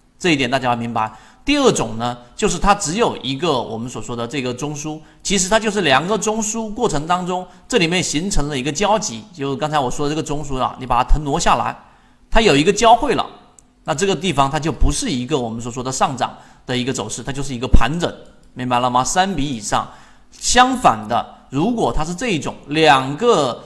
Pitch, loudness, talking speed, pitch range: 150 Hz, -18 LUFS, 320 characters per minute, 125-200 Hz